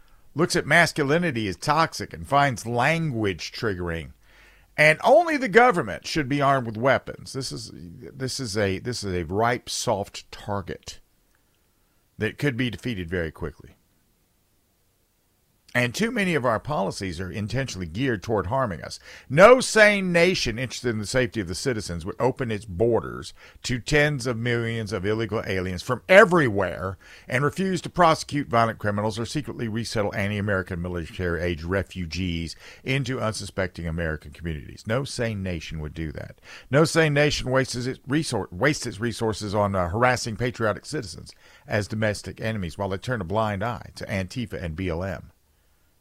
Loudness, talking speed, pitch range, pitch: -24 LUFS, 150 wpm, 95-130 Hz, 110 Hz